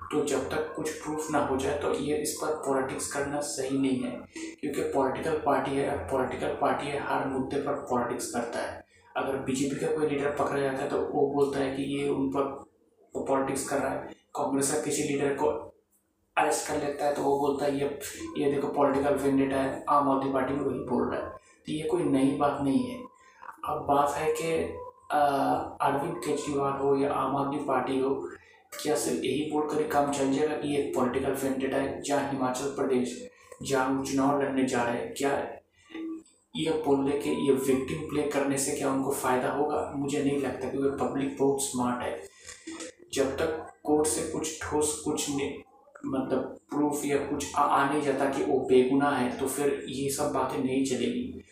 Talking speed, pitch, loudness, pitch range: 190 wpm, 140 Hz, -29 LUFS, 135-145 Hz